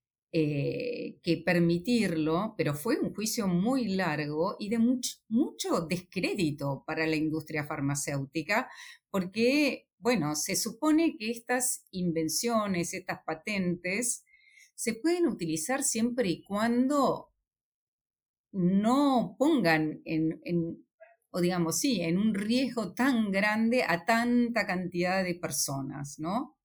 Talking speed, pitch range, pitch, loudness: 115 wpm, 165-245 Hz, 195 Hz, -29 LUFS